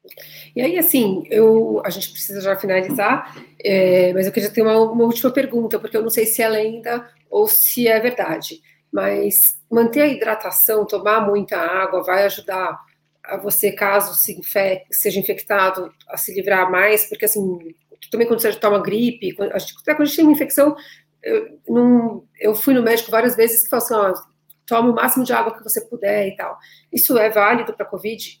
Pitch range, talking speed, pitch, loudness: 195-235 Hz, 190 wpm, 215 Hz, -17 LUFS